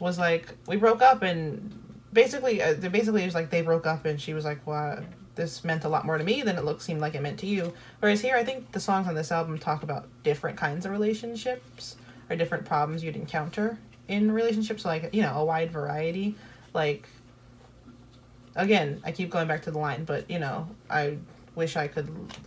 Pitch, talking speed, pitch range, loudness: 165 Hz, 215 wpm, 150-200 Hz, -28 LUFS